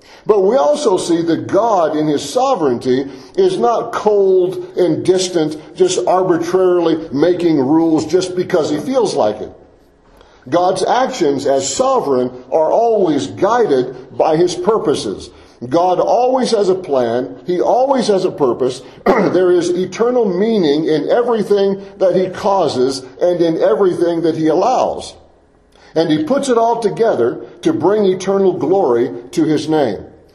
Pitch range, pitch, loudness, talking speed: 160-210 Hz, 180 Hz, -15 LUFS, 140 wpm